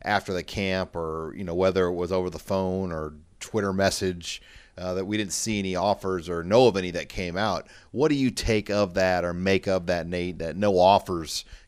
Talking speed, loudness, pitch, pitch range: 220 wpm, -26 LUFS, 95 Hz, 90-100 Hz